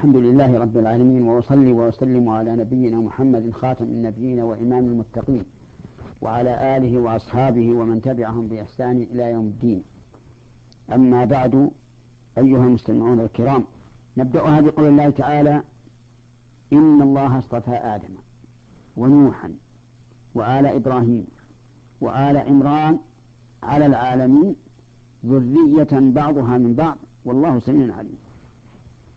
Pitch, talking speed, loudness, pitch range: 125 Hz, 100 wpm, -12 LUFS, 120-135 Hz